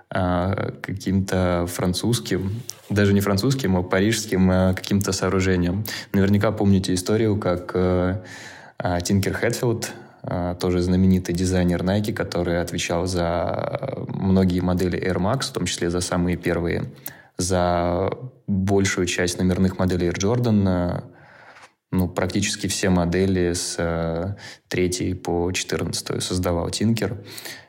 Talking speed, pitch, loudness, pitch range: 105 wpm, 95 Hz, -22 LUFS, 90-100 Hz